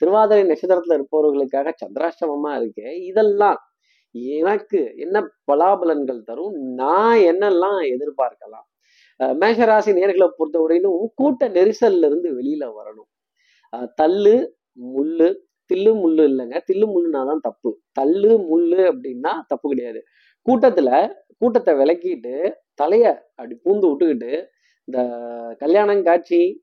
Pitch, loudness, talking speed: 225 Hz, -18 LUFS, 100 wpm